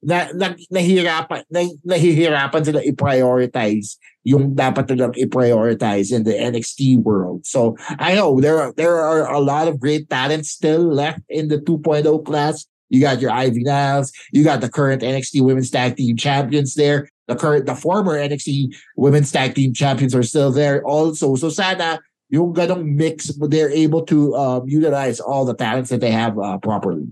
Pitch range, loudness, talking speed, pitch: 130-155 Hz, -17 LUFS, 175 wpm, 145 Hz